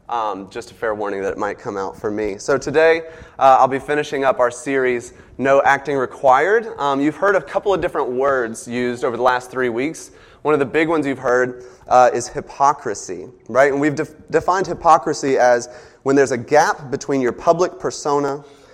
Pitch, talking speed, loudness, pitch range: 140 Hz, 200 wpm, -18 LUFS, 125-160 Hz